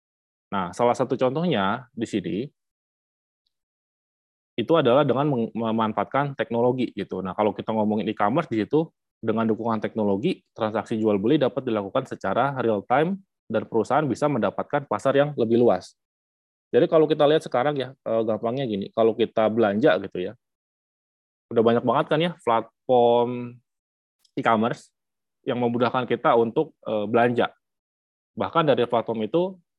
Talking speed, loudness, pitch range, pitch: 135 wpm, -23 LUFS, 105-130 Hz, 115 Hz